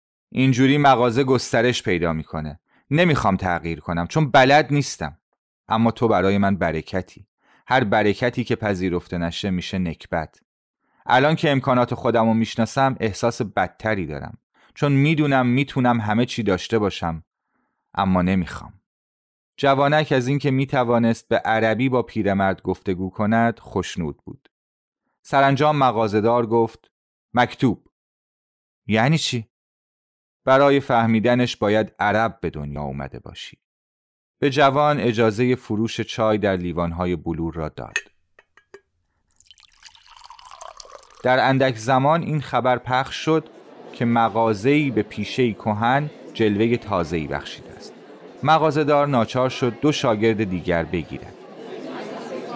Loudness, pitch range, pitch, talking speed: -20 LUFS, 95-135 Hz, 115 Hz, 115 wpm